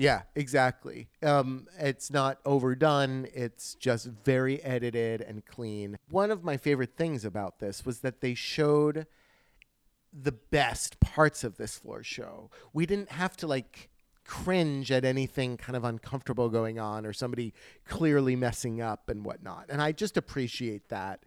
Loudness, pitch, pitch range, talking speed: -30 LUFS, 130 Hz, 120-145 Hz, 155 wpm